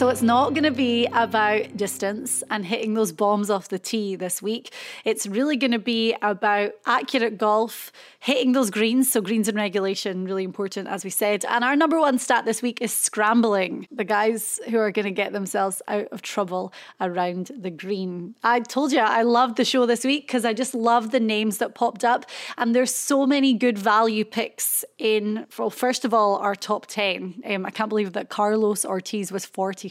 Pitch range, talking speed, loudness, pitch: 205-245 Hz, 205 wpm, -23 LUFS, 220 Hz